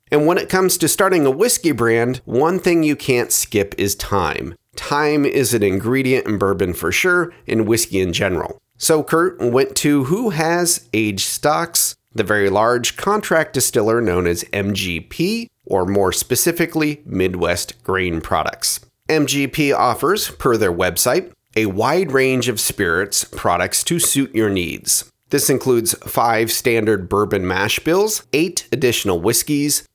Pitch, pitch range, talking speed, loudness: 120 Hz, 100-155 Hz, 150 wpm, -17 LUFS